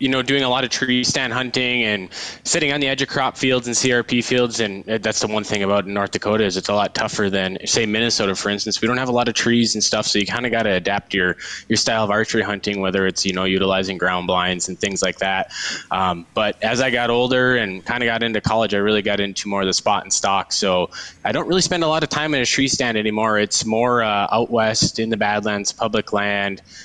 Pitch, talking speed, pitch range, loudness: 110 Hz, 260 wpm, 100-125 Hz, -19 LUFS